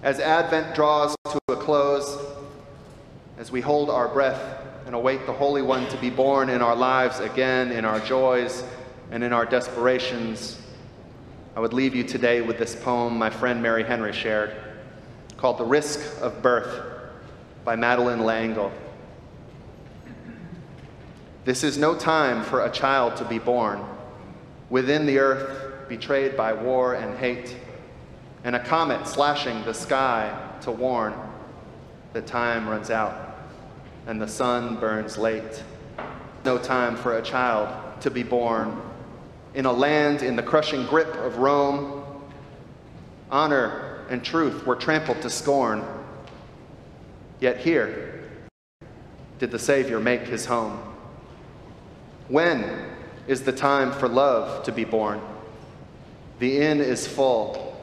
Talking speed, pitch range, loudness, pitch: 135 wpm, 115-140 Hz, -24 LUFS, 125 Hz